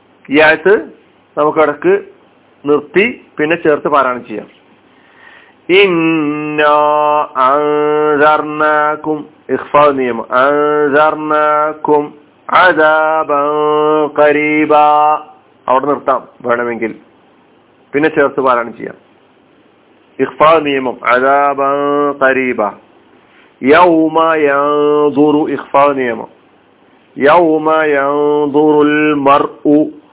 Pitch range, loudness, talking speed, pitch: 145-155 Hz, -11 LUFS, 40 wpm, 150 Hz